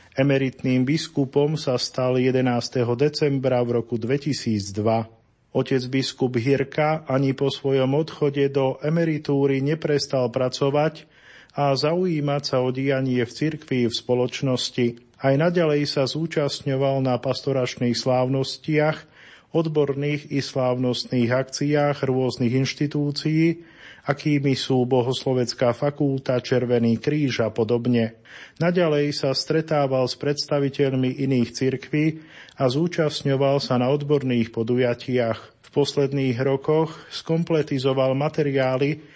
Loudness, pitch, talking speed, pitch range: -23 LUFS, 135 Hz, 105 wpm, 125-145 Hz